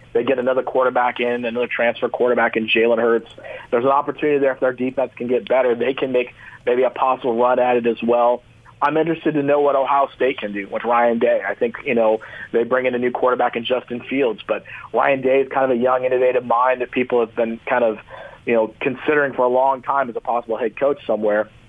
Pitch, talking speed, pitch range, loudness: 125 Hz, 240 wpm, 115-130 Hz, -19 LUFS